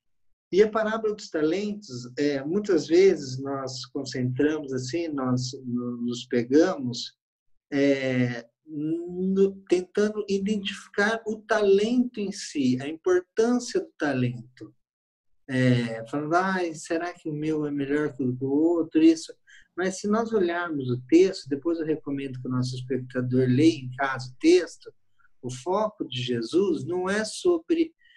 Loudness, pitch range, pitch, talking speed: -26 LUFS, 130-210 Hz, 155 Hz, 140 wpm